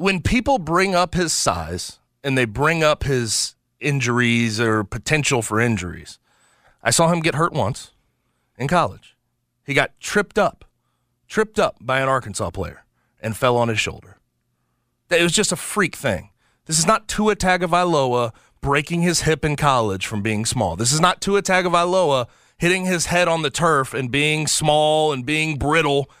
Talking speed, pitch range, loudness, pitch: 175 wpm, 115-175 Hz, -19 LUFS, 145 Hz